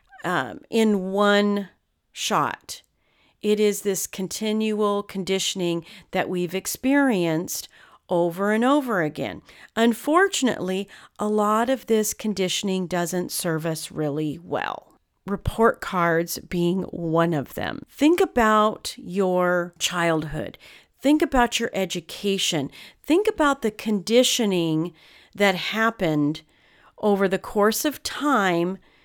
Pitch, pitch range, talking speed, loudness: 195 Hz, 175-220 Hz, 105 wpm, -23 LUFS